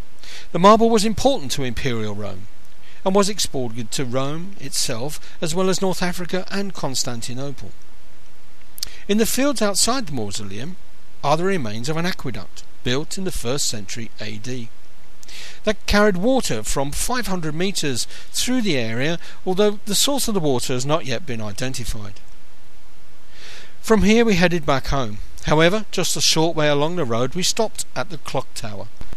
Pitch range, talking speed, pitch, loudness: 115-195 Hz, 160 wpm, 150 Hz, -21 LUFS